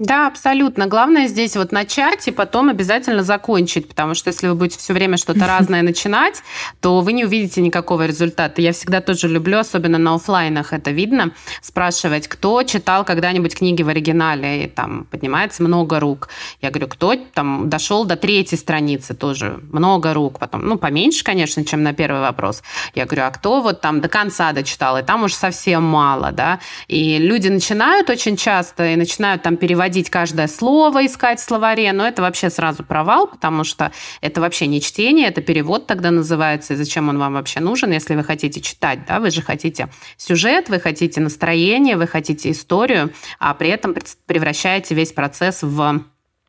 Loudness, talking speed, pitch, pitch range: -17 LUFS, 180 wpm, 175 Hz, 155-205 Hz